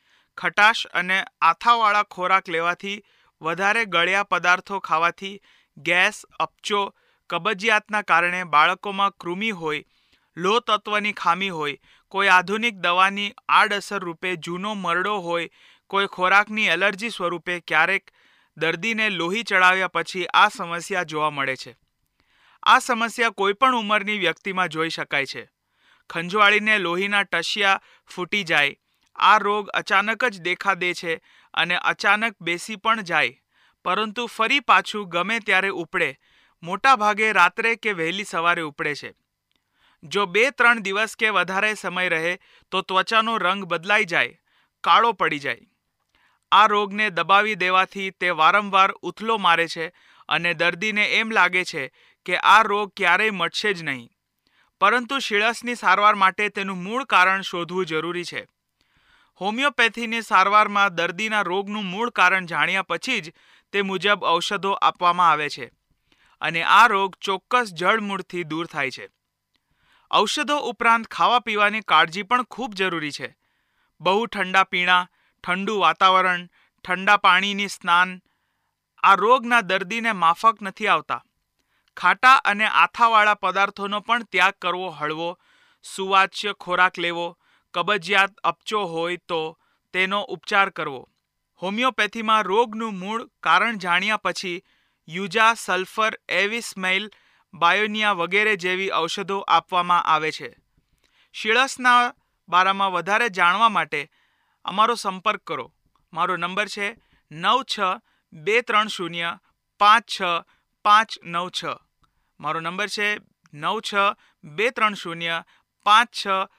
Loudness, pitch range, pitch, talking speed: -21 LUFS, 175-215 Hz, 195 Hz, 120 wpm